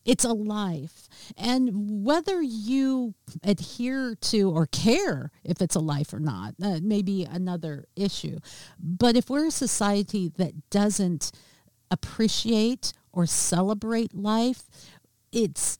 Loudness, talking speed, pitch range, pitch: -26 LUFS, 125 wpm, 165-230 Hz, 200 Hz